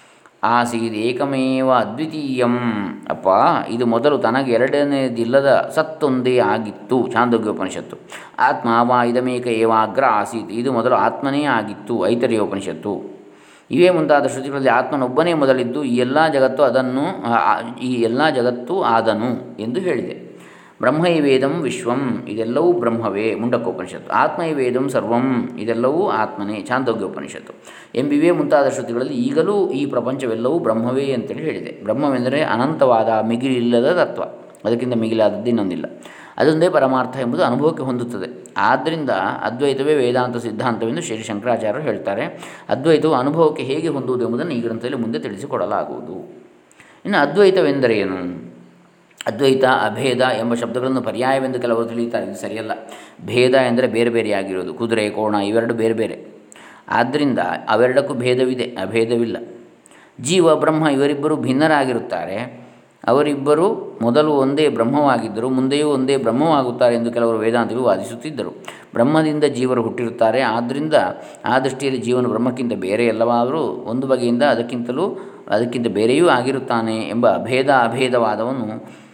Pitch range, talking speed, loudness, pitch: 115-135 Hz, 110 wpm, -18 LUFS, 125 Hz